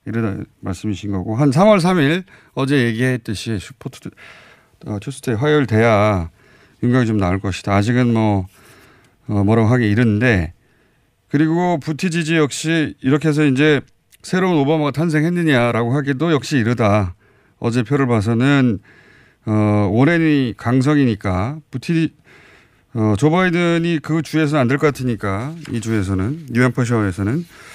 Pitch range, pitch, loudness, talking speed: 110-150 Hz, 125 Hz, -17 LUFS, 305 characters per minute